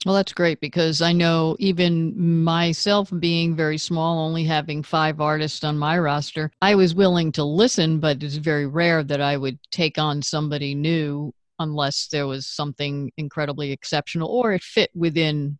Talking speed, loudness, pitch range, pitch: 170 wpm, -21 LUFS, 150-170 Hz, 155 Hz